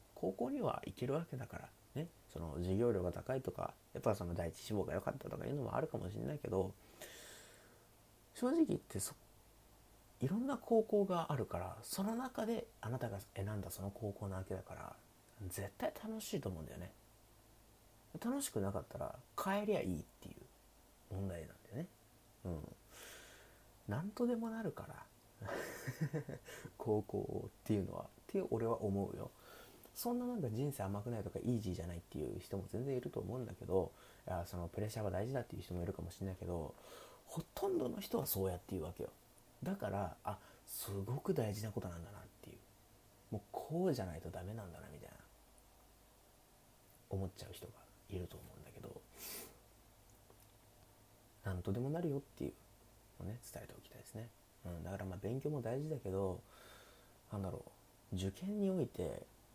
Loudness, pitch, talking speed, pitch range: -43 LUFS, 110 Hz, 345 characters per minute, 95-130 Hz